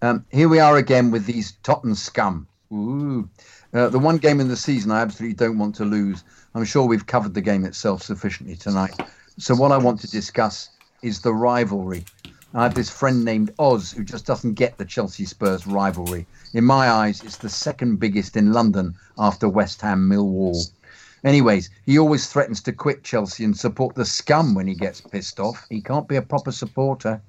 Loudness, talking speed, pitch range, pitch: -21 LUFS, 200 wpm, 100-130 Hz, 110 Hz